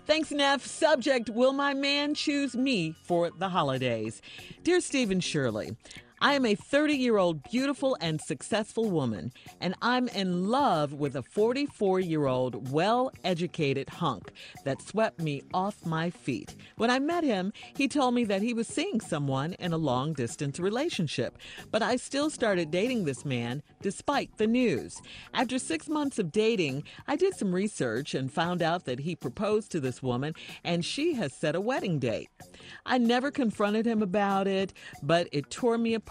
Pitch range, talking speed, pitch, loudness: 155-250 Hz, 175 wpm, 195 Hz, -29 LUFS